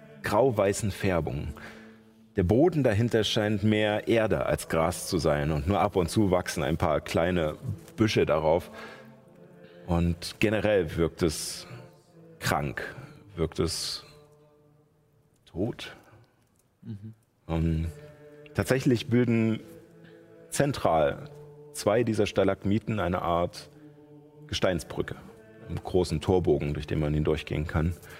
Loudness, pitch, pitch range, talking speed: -27 LUFS, 110 Hz, 90-145 Hz, 105 wpm